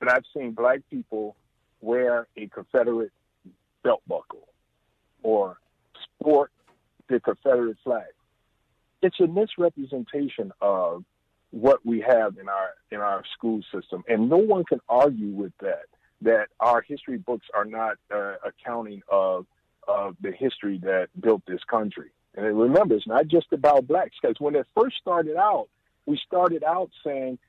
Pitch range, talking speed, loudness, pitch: 110-150 Hz, 150 wpm, -25 LUFS, 120 Hz